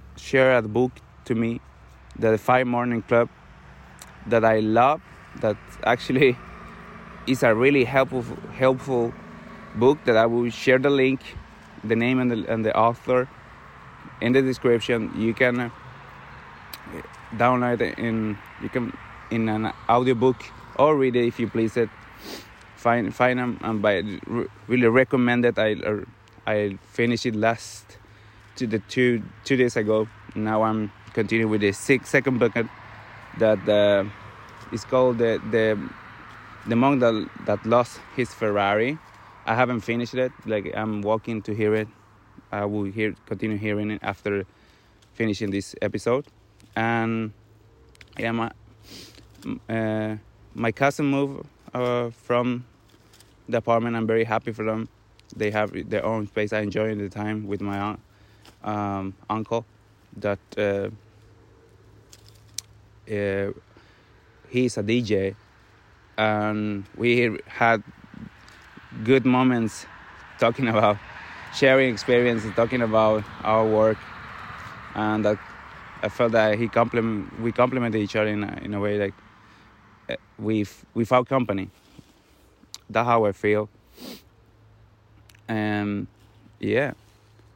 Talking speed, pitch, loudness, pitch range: 130 wpm, 110 Hz, -24 LUFS, 105-120 Hz